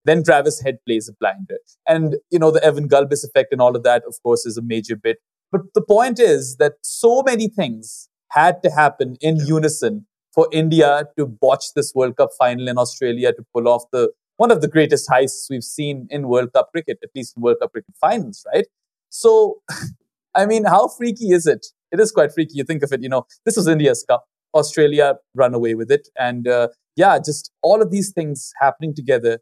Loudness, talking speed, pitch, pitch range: -17 LUFS, 215 wpm, 150 Hz, 125-190 Hz